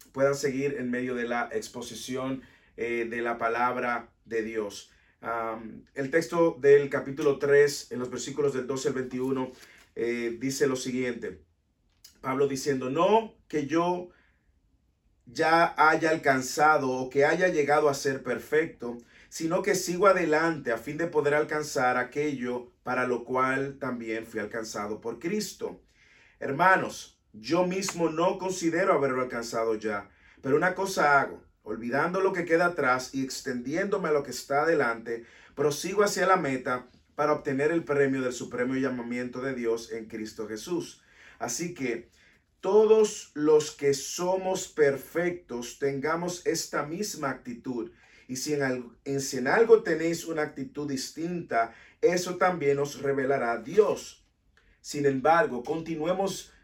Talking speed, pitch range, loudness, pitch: 140 wpm, 120-160 Hz, -27 LUFS, 140 Hz